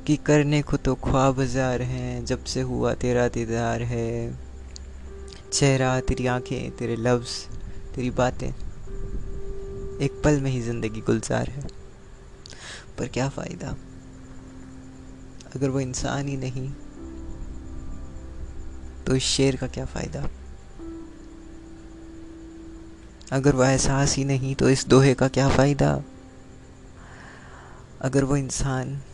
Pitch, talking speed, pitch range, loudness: 125 Hz, 110 wpm, 95-135 Hz, -24 LUFS